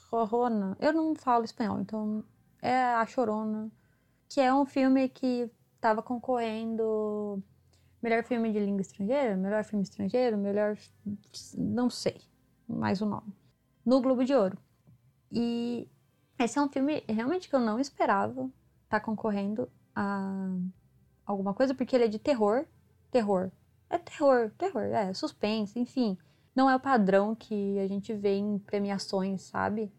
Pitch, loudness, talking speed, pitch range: 220 Hz, -30 LUFS, 150 wpm, 200-250 Hz